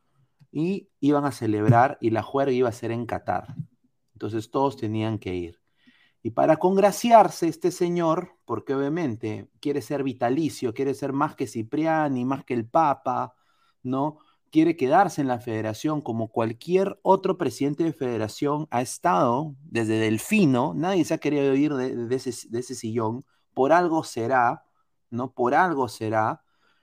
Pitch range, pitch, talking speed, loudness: 115-155 Hz, 135 Hz, 160 wpm, -24 LUFS